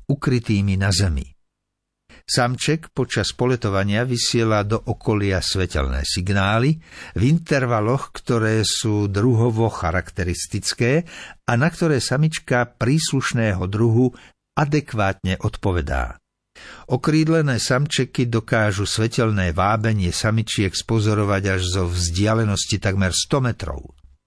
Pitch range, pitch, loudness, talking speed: 95-125 Hz, 110 Hz, -20 LUFS, 95 wpm